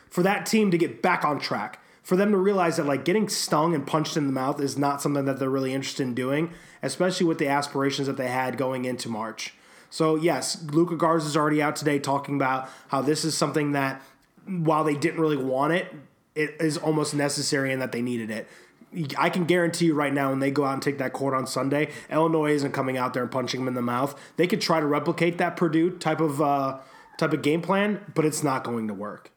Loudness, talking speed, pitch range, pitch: -25 LUFS, 240 wpm, 135-165 Hz, 145 Hz